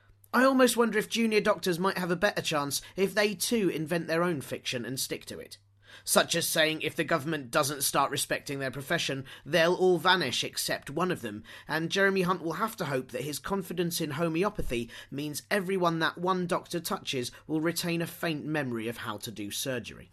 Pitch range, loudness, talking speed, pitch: 135-185 Hz, -29 LUFS, 205 wpm, 165 Hz